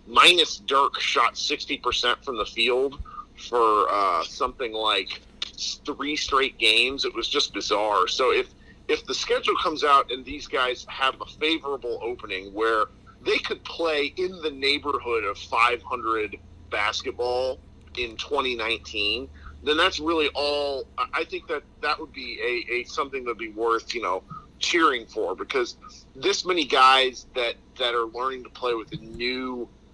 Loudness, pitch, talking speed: -24 LUFS, 145 Hz, 160 wpm